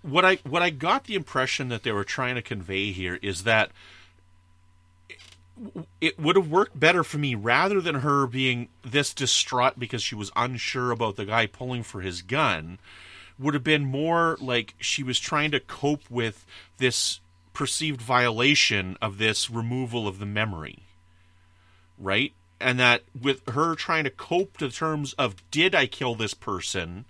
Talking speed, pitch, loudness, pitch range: 170 wpm, 120 Hz, -25 LUFS, 95-145 Hz